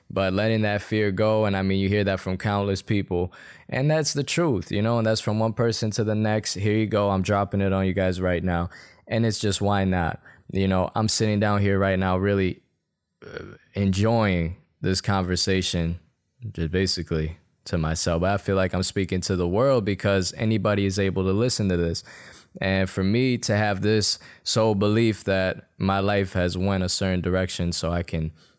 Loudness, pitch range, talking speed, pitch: -23 LUFS, 90-110 Hz, 200 wpm, 100 Hz